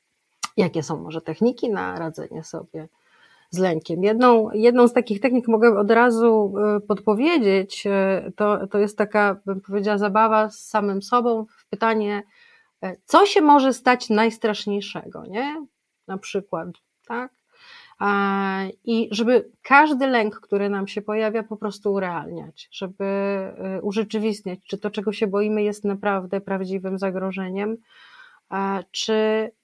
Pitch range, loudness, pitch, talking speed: 195-230 Hz, -21 LUFS, 210 Hz, 125 wpm